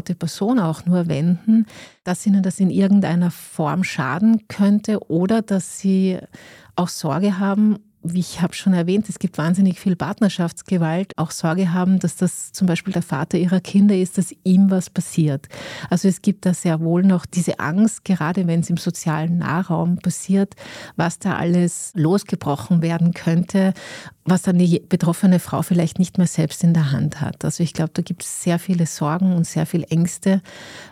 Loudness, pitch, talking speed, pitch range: -19 LUFS, 180 Hz, 180 wpm, 170-190 Hz